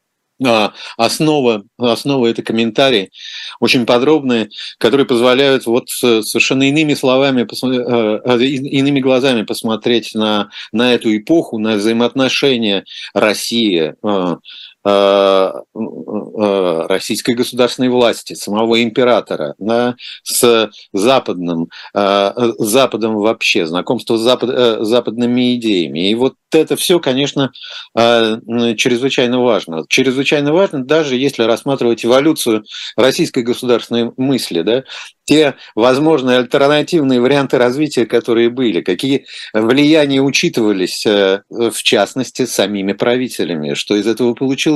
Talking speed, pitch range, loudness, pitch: 105 wpm, 110-135 Hz, -14 LUFS, 120 Hz